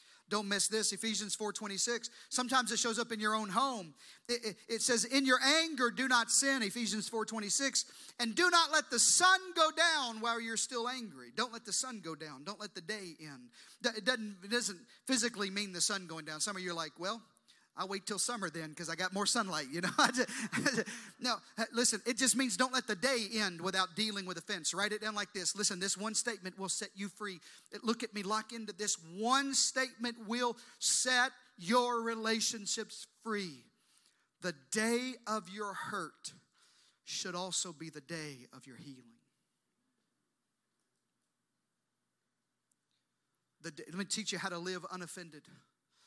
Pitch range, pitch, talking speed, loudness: 190-240 Hz, 215 Hz, 185 wpm, -34 LUFS